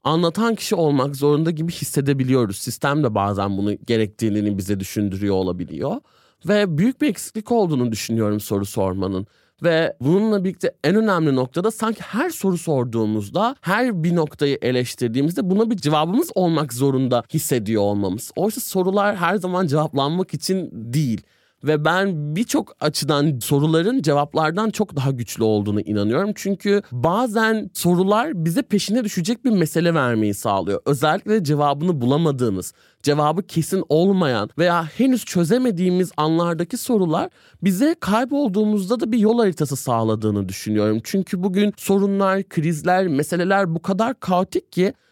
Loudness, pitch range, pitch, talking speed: -20 LUFS, 125-200 Hz, 165 Hz, 130 wpm